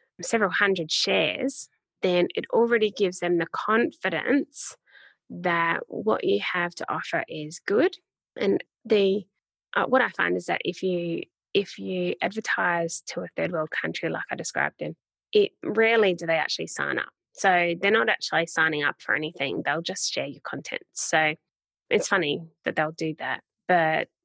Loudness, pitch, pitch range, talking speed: -25 LUFS, 175 Hz, 160-215 Hz, 170 wpm